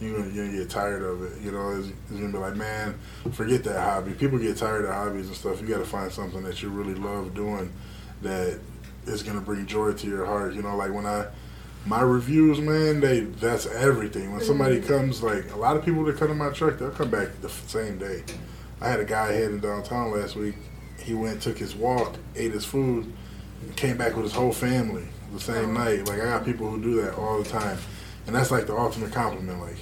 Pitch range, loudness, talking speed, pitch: 100-120 Hz, -27 LUFS, 230 wpm, 105 Hz